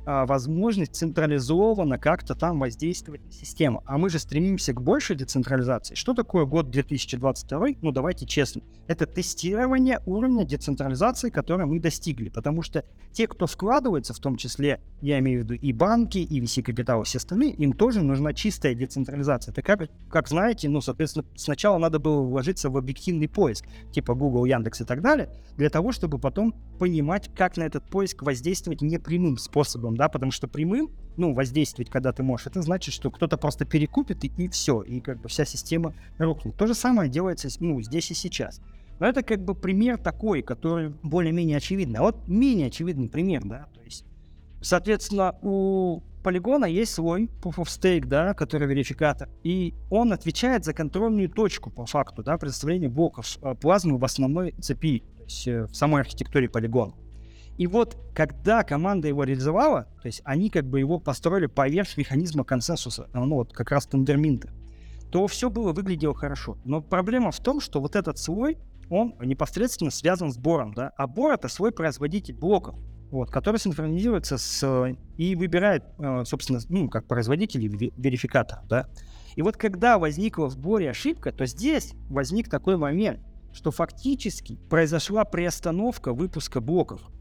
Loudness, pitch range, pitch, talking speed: -26 LUFS, 135-185 Hz, 155 Hz, 165 wpm